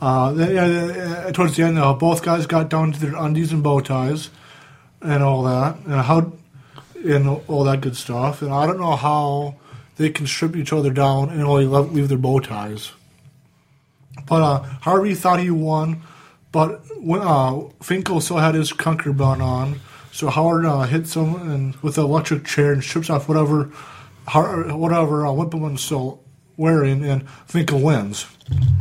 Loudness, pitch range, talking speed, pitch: -19 LUFS, 135-160 Hz, 170 wpm, 150 Hz